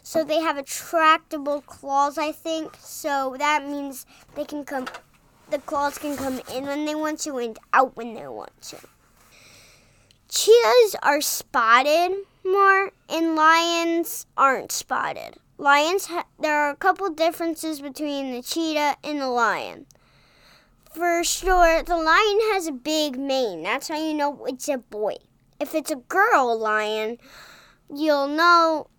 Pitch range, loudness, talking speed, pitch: 280-330 Hz, -22 LUFS, 145 wpm, 300 Hz